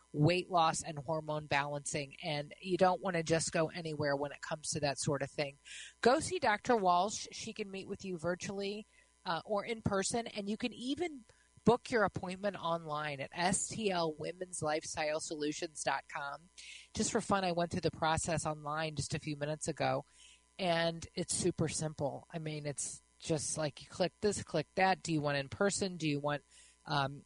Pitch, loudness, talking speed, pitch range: 165 Hz, -36 LUFS, 185 wpm, 150-190 Hz